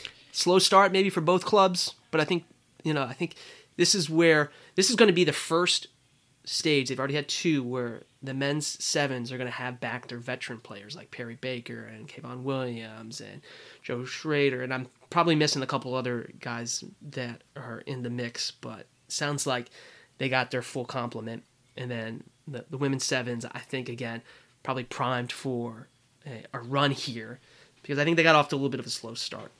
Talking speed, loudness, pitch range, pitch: 205 wpm, -27 LUFS, 125-150 Hz, 130 Hz